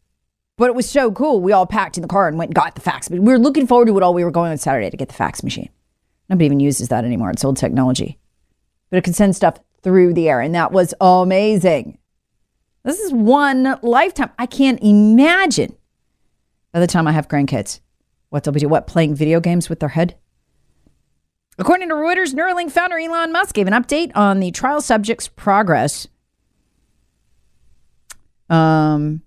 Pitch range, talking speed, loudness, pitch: 155-250 Hz, 195 wpm, -16 LUFS, 185 Hz